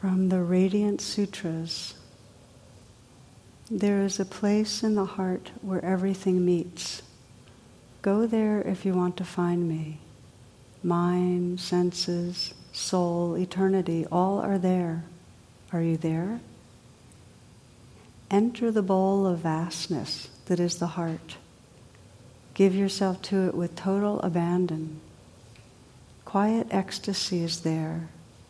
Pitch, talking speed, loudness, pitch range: 175 Hz, 110 wpm, -27 LUFS, 130-190 Hz